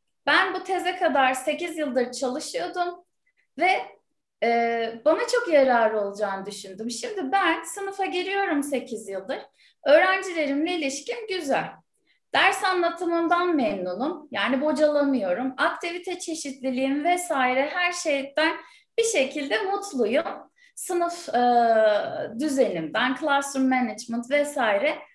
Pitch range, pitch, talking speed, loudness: 255-355 Hz, 300 Hz, 95 wpm, -24 LUFS